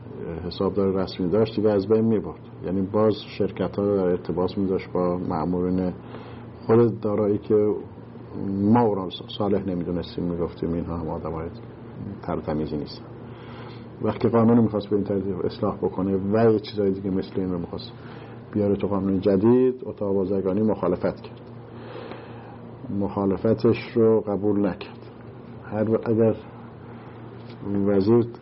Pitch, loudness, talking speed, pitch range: 105 Hz, -24 LUFS, 135 wpm, 95-115 Hz